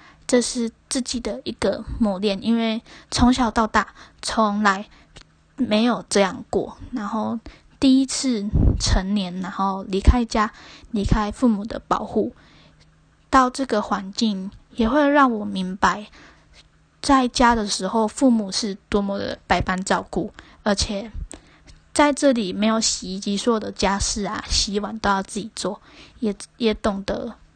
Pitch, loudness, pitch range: 220 Hz, -22 LUFS, 200-245 Hz